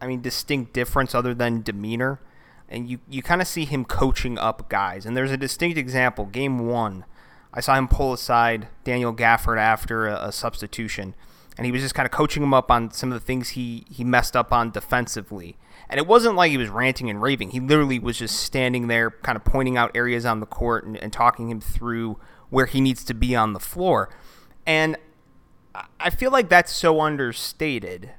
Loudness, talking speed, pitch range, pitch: -22 LUFS, 210 wpm, 115-135 Hz, 125 Hz